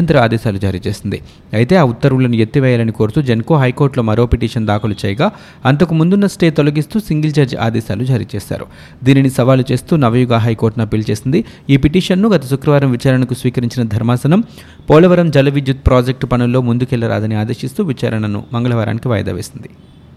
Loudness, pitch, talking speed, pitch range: -14 LUFS, 125 Hz, 140 wpm, 115-145 Hz